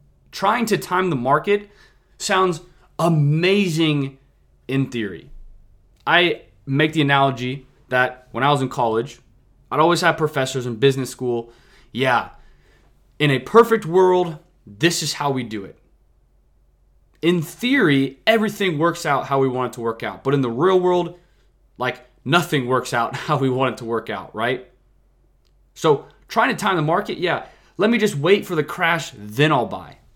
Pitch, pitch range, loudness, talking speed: 140 Hz, 125-170 Hz, -20 LUFS, 165 wpm